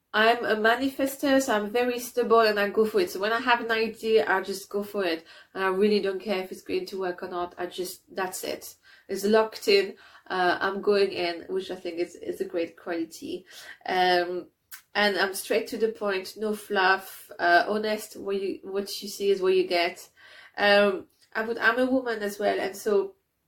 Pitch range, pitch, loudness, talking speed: 190-230 Hz, 205 Hz, -26 LUFS, 215 wpm